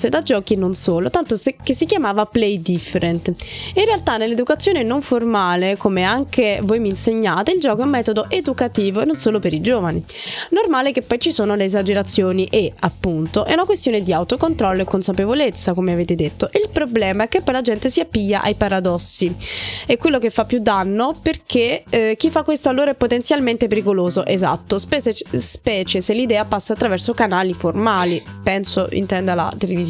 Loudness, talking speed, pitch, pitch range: -18 LUFS, 185 wpm, 220 Hz, 190-260 Hz